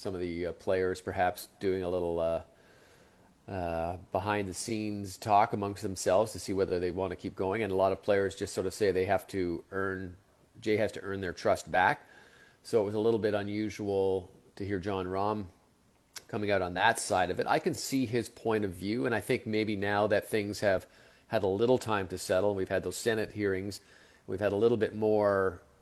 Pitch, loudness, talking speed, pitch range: 100 Hz, -31 LUFS, 215 wpm, 95-105 Hz